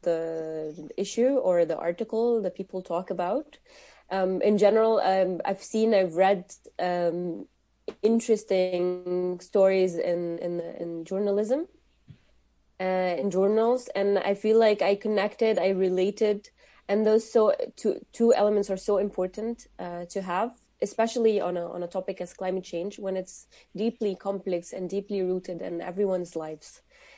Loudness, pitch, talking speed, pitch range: -27 LUFS, 195 Hz, 145 wpm, 180-215 Hz